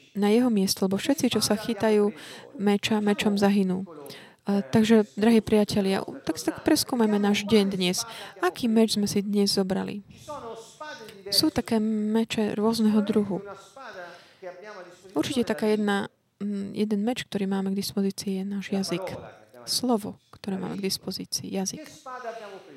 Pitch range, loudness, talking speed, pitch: 195-225 Hz, -25 LUFS, 130 wpm, 205 Hz